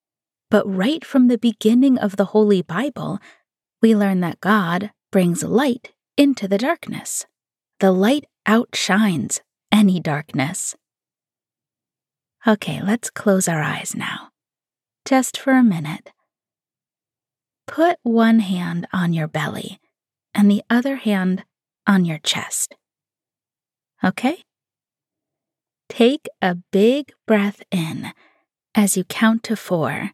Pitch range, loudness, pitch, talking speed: 185-235 Hz, -19 LUFS, 210 Hz, 115 wpm